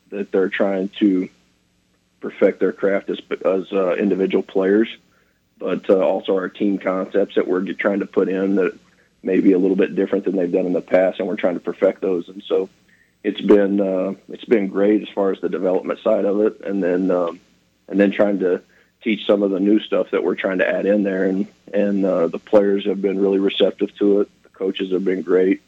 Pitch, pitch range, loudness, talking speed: 95 Hz, 95-100 Hz, -19 LUFS, 220 wpm